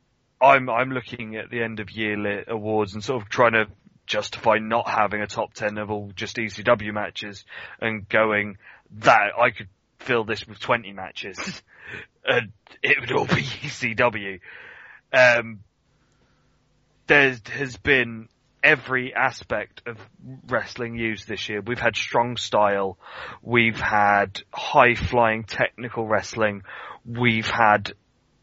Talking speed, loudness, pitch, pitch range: 135 wpm, -22 LUFS, 110 Hz, 105-120 Hz